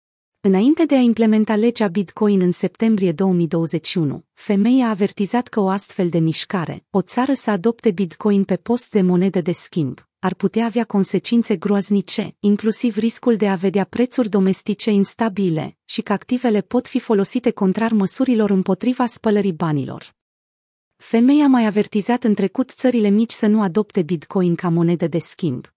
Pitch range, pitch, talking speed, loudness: 185-230 Hz, 205 Hz, 155 wpm, -18 LUFS